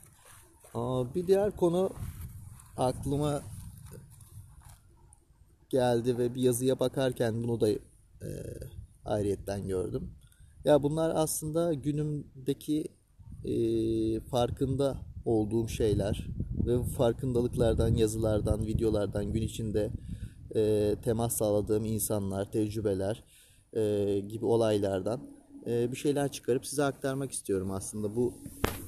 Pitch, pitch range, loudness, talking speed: 115 Hz, 105-130 Hz, -31 LUFS, 95 wpm